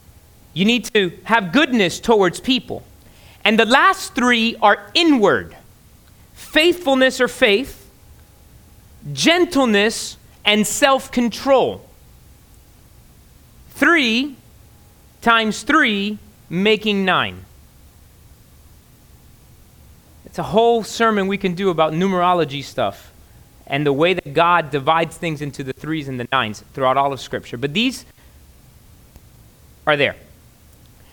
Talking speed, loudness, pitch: 110 wpm, -17 LUFS, 195 Hz